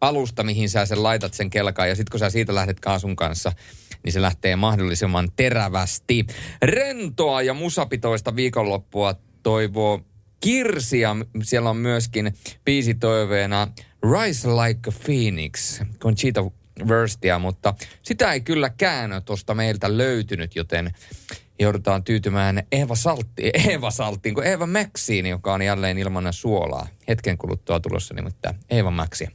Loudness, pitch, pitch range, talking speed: -22 LUFS, 110 Hz, 95-120 Hz, 125 wpm